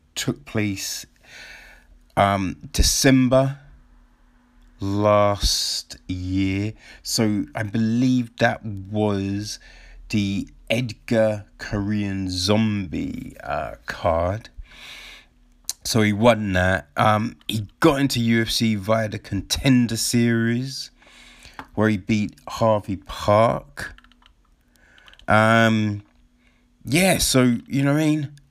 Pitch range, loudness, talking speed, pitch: 100-115 Hz, -21 LUFS, 90 wpm, 110 Hz